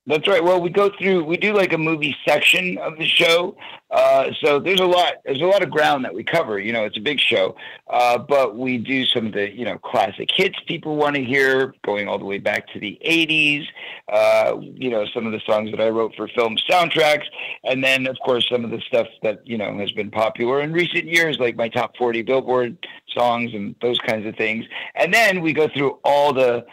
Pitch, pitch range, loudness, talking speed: 140 Hz, 120-170 Hz, -19 LUFS, 235 wpm